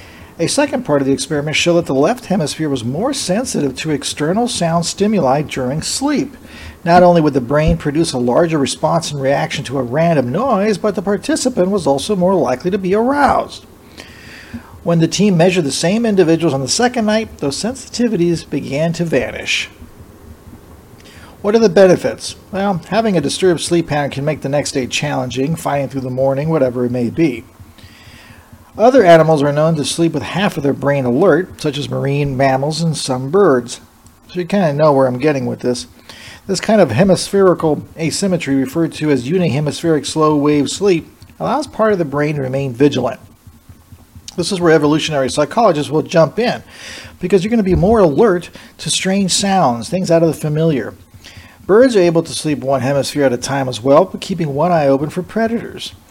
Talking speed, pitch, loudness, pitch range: 190 wpm, 155 Hz, -15 LUFS, 135-185 Hz